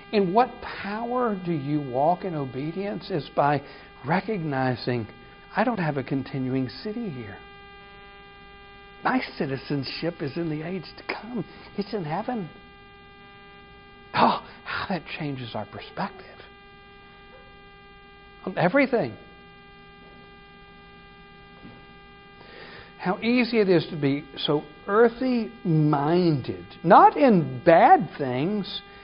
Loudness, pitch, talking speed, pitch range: -25 LUFS, 180 Hz, 100 wpm, 135-200 Hz